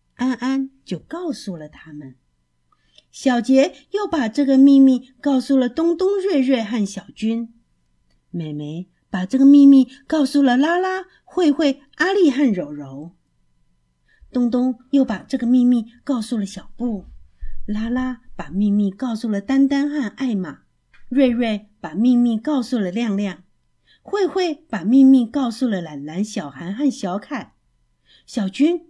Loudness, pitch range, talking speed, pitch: -19 LUFS, 190-275 Hz, 205 characters per minute, 245 Hz